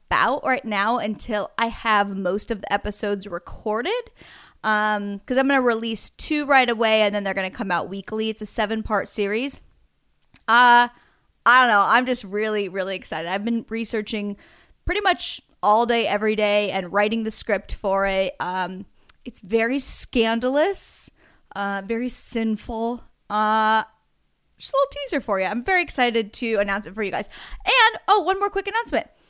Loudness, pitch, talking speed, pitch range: -22 LUFS, 220 Hz, 175 wpm, 205-245 Hz